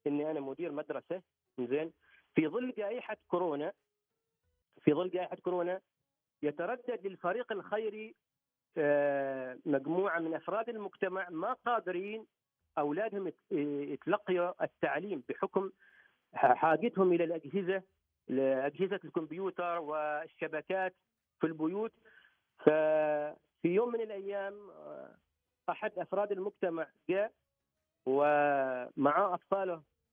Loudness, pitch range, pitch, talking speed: -34 LUFS, 145-195 Hz, 175 Hz, 90 wpm